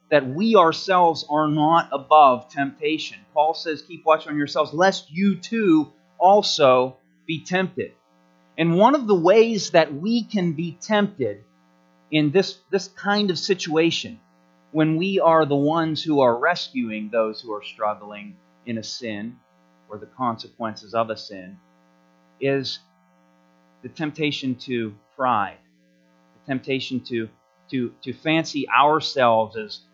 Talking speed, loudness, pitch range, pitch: 140 wpm, -21 LUFS, 100-165 Hz, 140 Hz